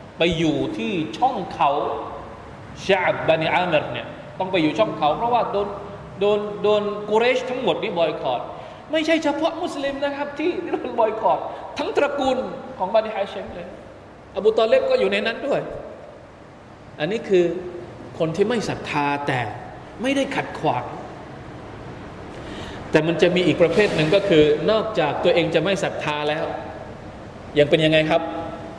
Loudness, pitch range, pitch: -21 LUFS, 155-225 Hz, 180 Hz